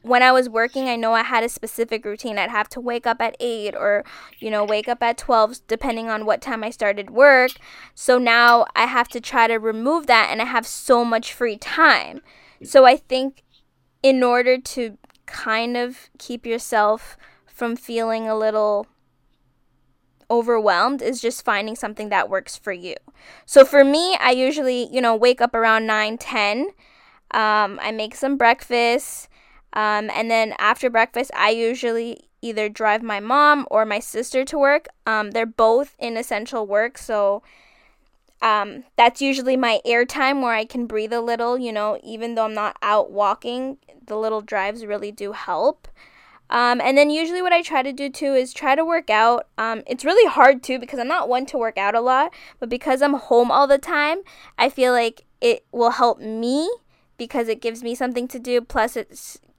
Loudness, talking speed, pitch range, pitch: -19 LUFS, 190 wpm, 220-260 Hz, 235 Hz